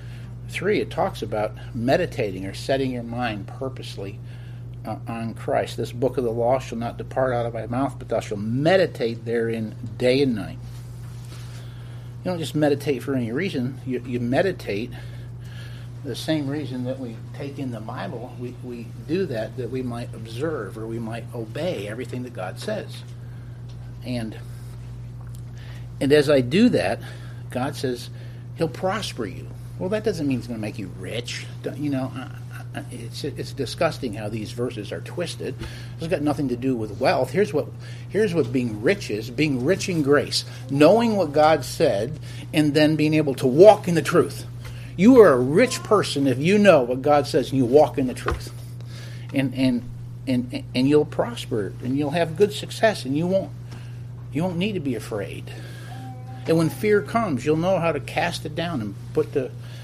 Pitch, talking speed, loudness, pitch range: 125 Hz, 185 wpm, -23 LUFS, 120-140 Hz